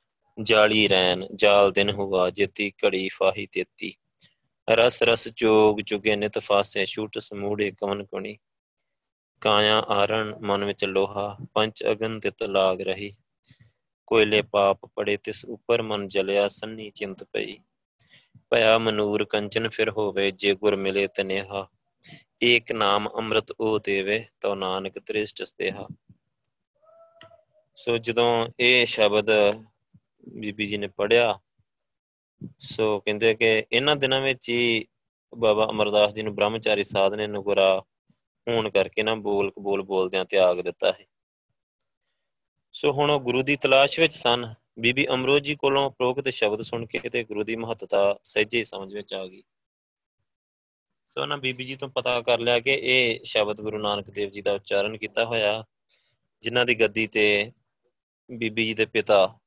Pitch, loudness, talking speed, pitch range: 110 Hz, -23 LUFS, 140 wpm, 100-120 Hz